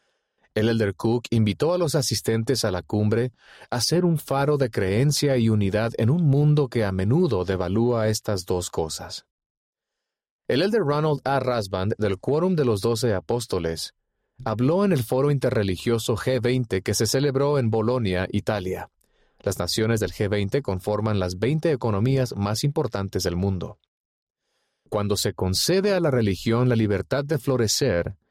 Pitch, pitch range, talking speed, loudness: 115 Hz, 105-135 Hz, 155 wpm, -23 LUFS